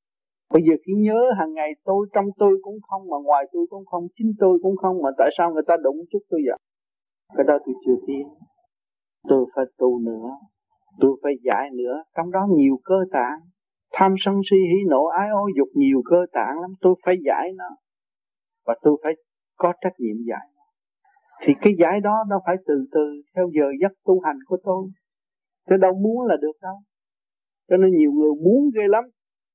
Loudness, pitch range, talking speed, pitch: -21 LUFS, 145-195 Hz, 200 wpm, 180 Hz